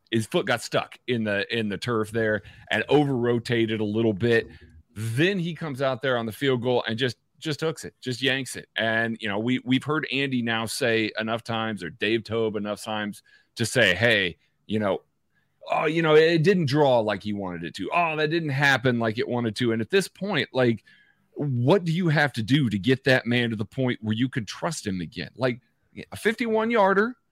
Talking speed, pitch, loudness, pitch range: 220 wpm, 120 Hz, -24 LUFS, 110-145 Hz